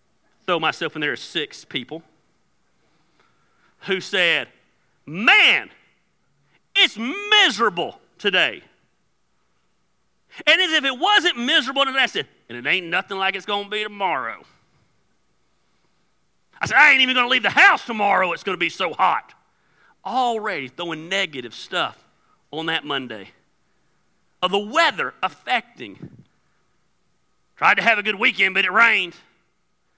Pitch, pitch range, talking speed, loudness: 195 Hz, 160-260 Hz, 140 wpm, -19 LUFS